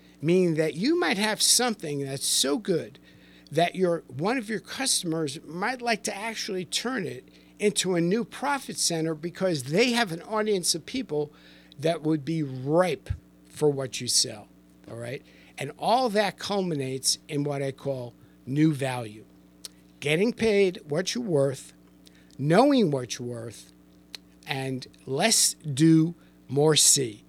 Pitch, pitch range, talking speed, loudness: 155 Hz, 125-200 Hz, 145 wpm, -25 LUFS